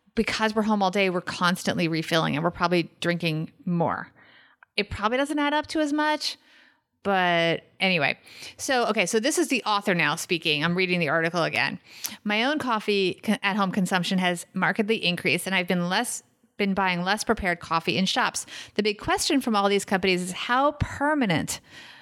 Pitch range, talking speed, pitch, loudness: 175-230 Hz, 180 wpm, 195 Hz, -25 LUFS